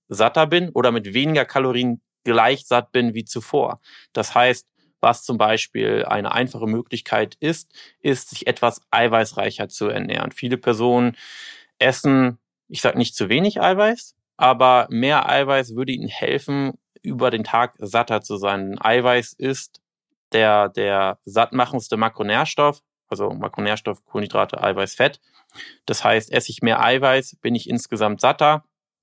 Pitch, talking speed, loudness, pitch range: 125 Hz, 140 wpm, -20 LUFS, 115-135 Hz